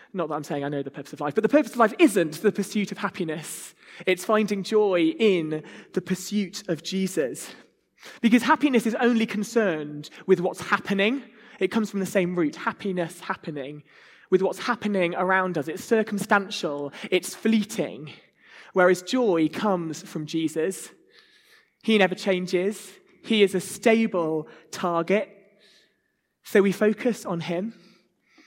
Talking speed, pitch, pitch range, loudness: 150 wpm, 195 Hz, 175-220 Hz, -24 LUFS